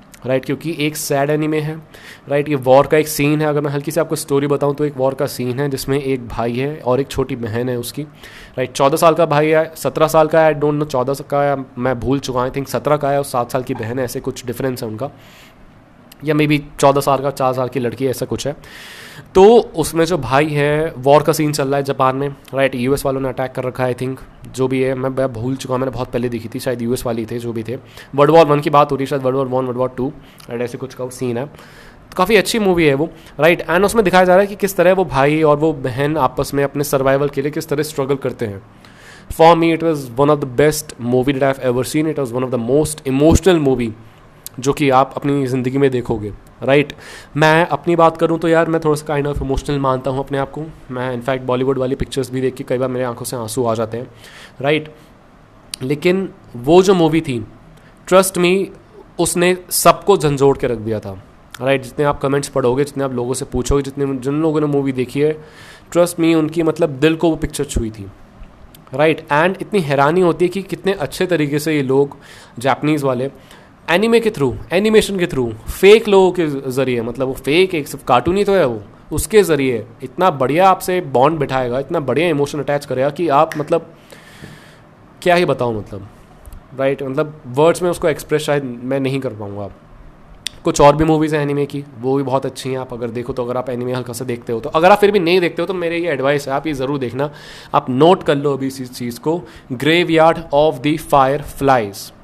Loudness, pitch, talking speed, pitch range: -16 LUFS, 140 Hz, 235 wpm, 130-155 Hz